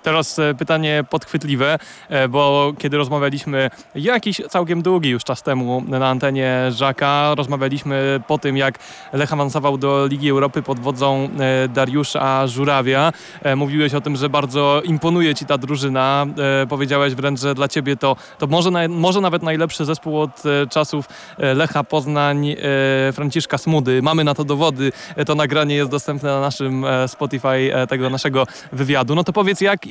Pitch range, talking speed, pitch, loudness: 135-155 Hz, 150 wpm, 145 Hz, -18 LUFS